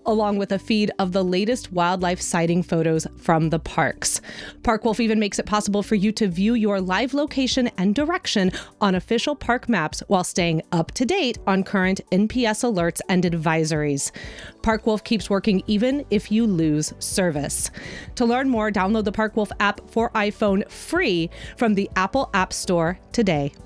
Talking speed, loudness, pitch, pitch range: 170 wpm, -22 LUFS, 205 Hz, 180-230 Hz